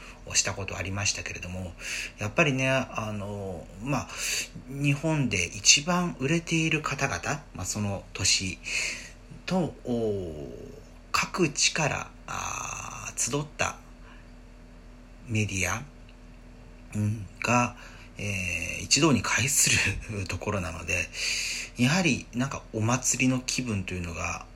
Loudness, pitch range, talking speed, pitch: -27 LUFS, 90-125 Hz, 205 characters per minute, 105 Hz